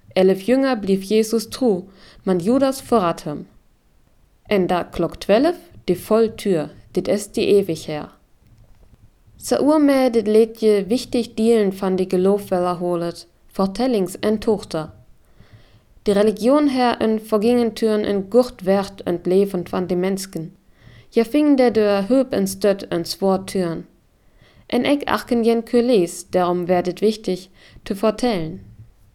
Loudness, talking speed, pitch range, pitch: -19 LUFS, 135 wpm, 180-230 Hz, 200 Hz